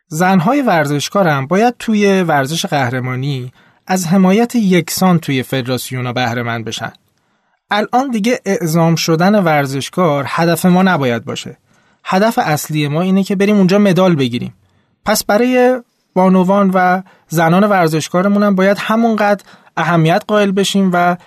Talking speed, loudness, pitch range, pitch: 130 wpm, -13 LUFS, 145-200 Hz, 185 Hz